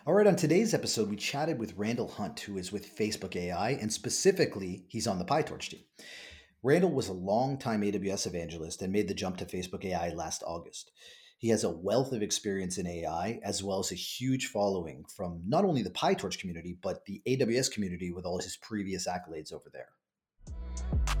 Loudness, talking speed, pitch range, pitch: -32 LUFS, 190 wpm, 90-110 Hz, 100 Hz